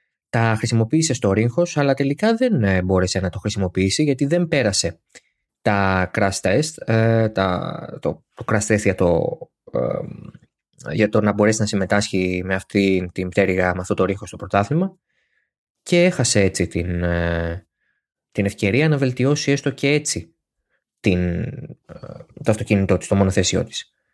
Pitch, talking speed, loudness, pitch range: 100 Hz, 140 wpm, -20 LUFS, 95-125 Hz